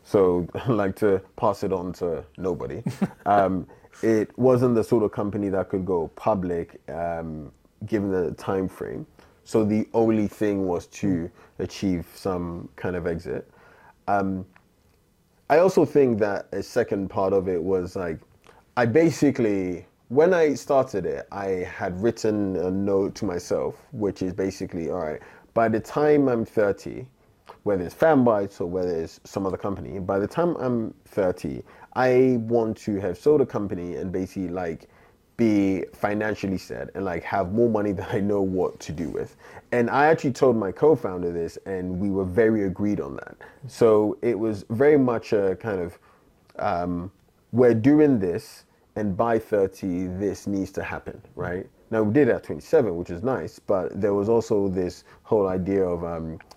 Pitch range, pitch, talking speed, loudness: 95-115 Hz, 100 Hz, 170 wpm, -24 LUFS